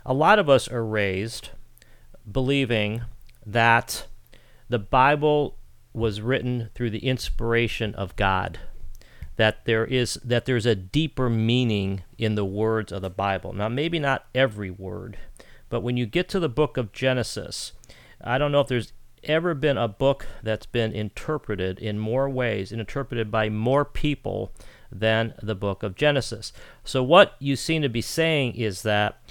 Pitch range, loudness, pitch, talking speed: 105-130 Hz, -24 LUFS, 115 Hz, 160 wpm